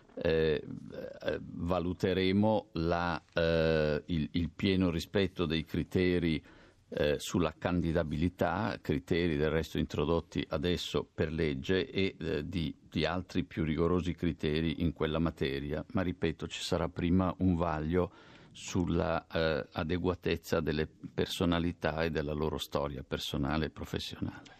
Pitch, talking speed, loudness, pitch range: 85 Hz, 125 wpm, -33 LUFS, 80-90 Hz